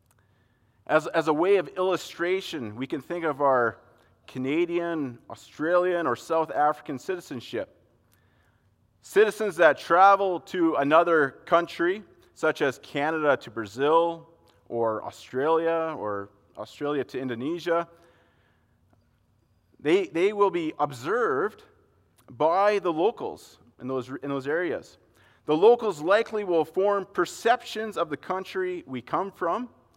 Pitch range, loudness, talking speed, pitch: 120-185 Hz, -26 LUFS, 120 wpm, 165 Hz